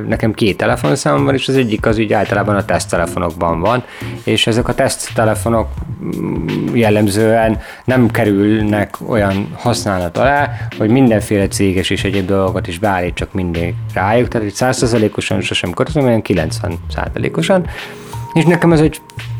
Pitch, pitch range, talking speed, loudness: 110 Hz, 100-120 Hz, 140 wpm, -15 LUFS